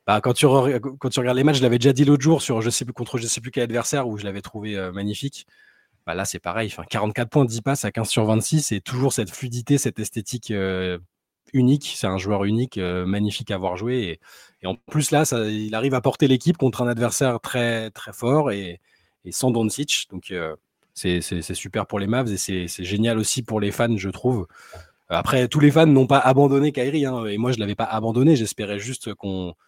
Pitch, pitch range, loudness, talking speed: 115 Hz, 100-130 Hz, -22 LUFS, 245 wpm